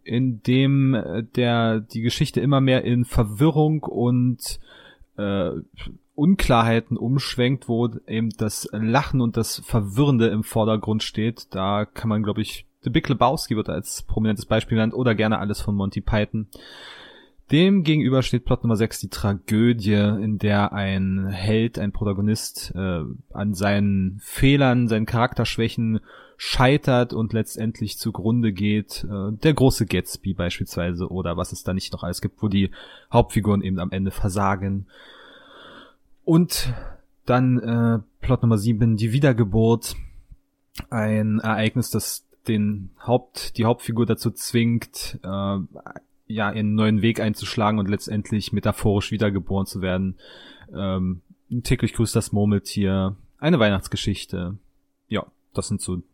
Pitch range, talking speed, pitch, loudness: 100-120 Hz, 135 wpm, 110 Hz, -22 LUFS